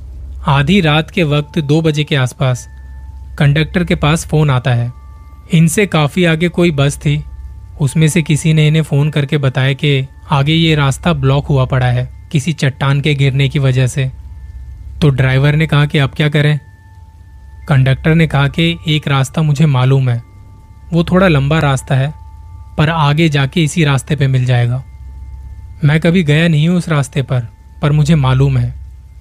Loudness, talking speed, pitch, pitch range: -13 LUFS, 175 wpm, 140 Hz, 120-155 Hz